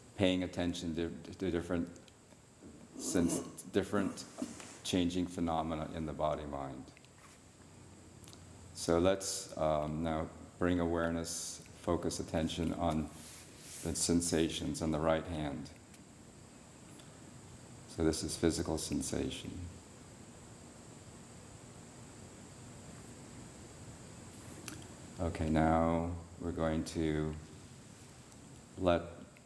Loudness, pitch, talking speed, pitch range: -36 LUFS, 85 Hz, 75 wpm, 80-85 Hz